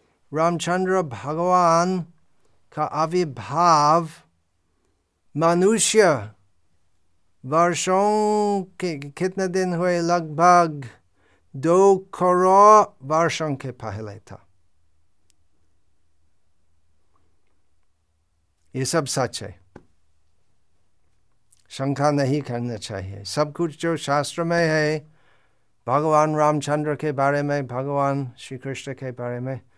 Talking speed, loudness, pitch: 85 wpm, -21 LUFS, 135 Hz